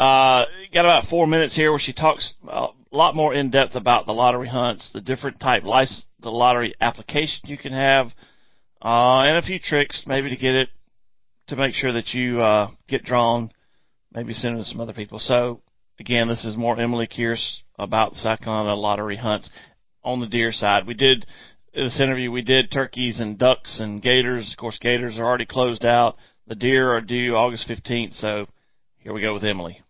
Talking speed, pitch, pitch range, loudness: 195 wpm, 120 Hz, 115-130 Hz, -21 LUFS